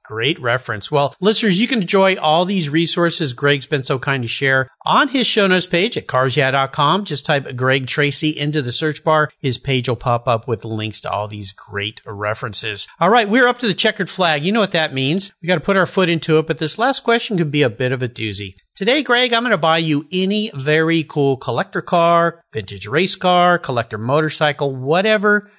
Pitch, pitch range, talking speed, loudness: 155 Hz, 130-190 Hz, 220 wpm, -17 LUFS